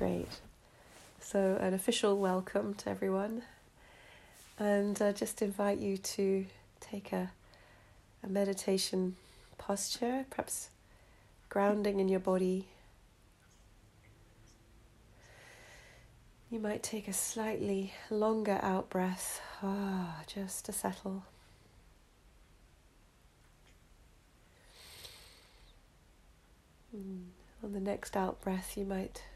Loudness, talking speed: -36 LUFS, 90 wpm